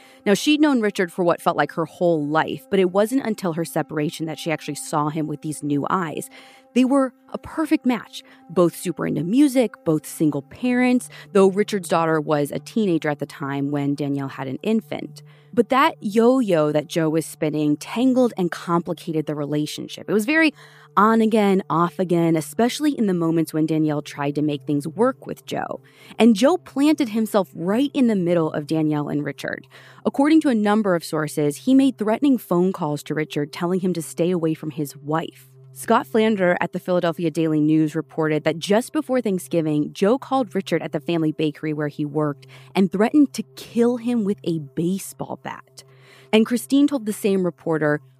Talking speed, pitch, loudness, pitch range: 195 wpm, 170 Hz, -21 LUFS, 155-225 Hz